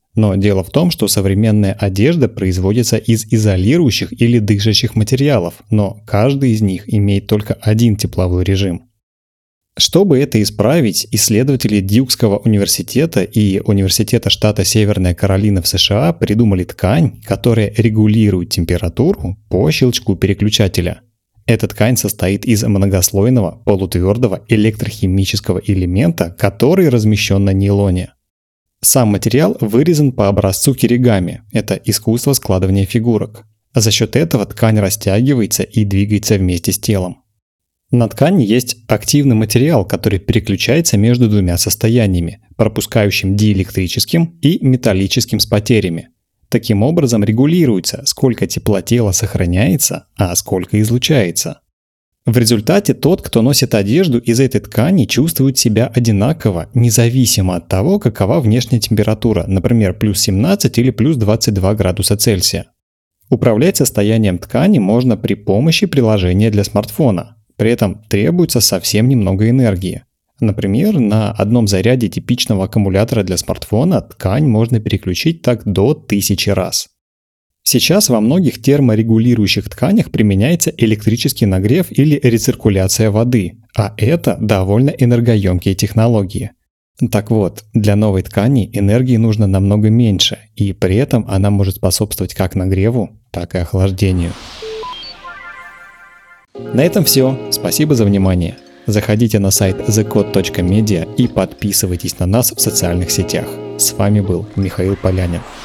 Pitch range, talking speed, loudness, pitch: 100-120 Hz, 120 wpm, -13 LUFS, 110 Hz